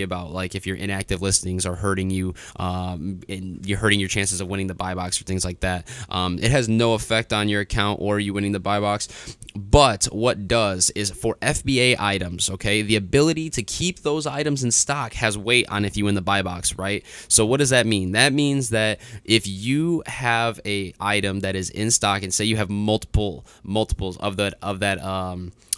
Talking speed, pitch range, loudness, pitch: 215 wpm, 95-115 Hz, -22 LUFS, 100 Hz